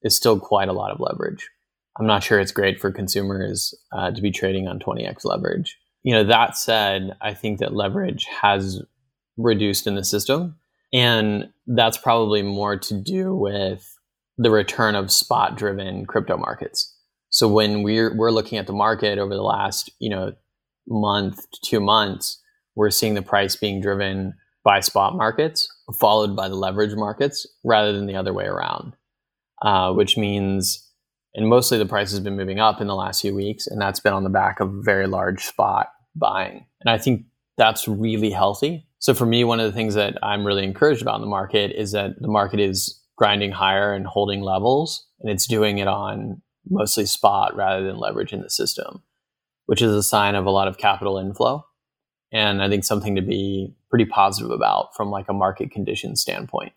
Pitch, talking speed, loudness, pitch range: 105 Hz, 190 wpm, -21 LUFS, 100-110 Hz